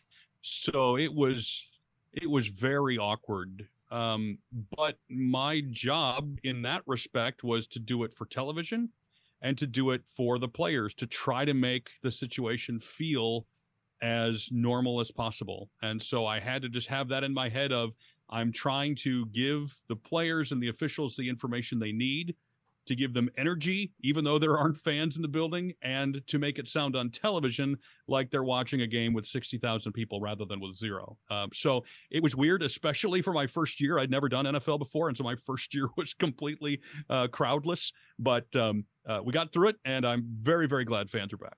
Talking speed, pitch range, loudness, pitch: 190 wpm, 115-145 Hz, -31 LUFS, 130 Hz